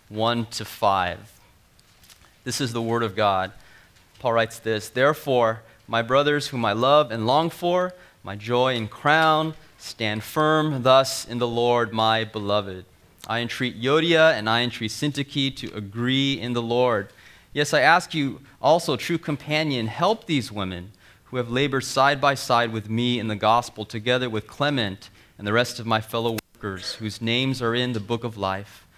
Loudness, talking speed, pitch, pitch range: -23 LUFS, 175 wpm, 120 Hz, 110-140 Hz